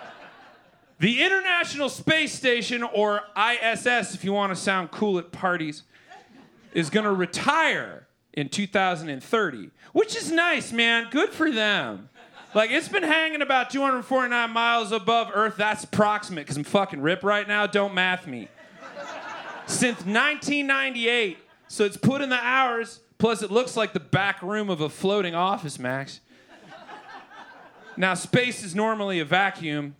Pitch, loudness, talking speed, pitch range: 210 Hz, -24 LUFS, 145 wpm, 185-245 Hz